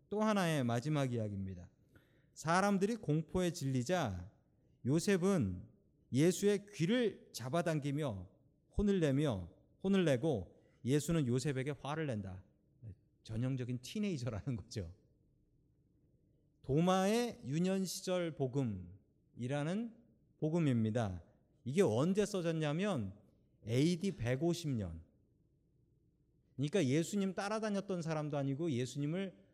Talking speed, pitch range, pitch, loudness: 240 characters per minute, 120-180 Hz, 145 Hz, -37 LUFS